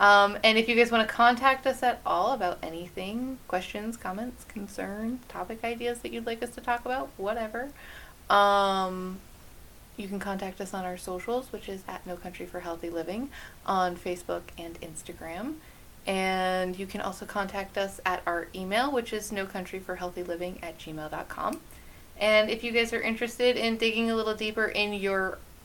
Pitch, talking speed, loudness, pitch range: 200 Hz, 180 wpm, -29 LUFS, 185-230 Hz